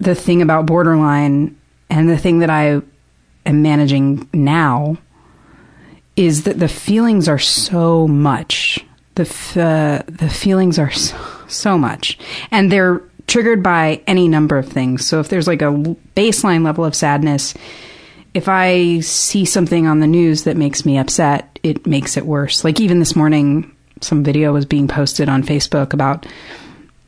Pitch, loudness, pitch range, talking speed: 155 Hz, -14 LUFS, 145-170 Hz, 160 wpm